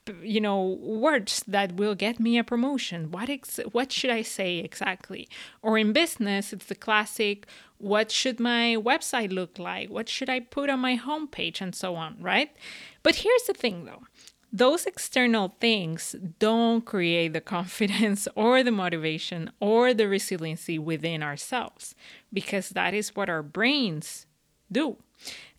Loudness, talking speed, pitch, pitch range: -26 LUFS, 155 wpm, 215 Hz, 185-245 Hz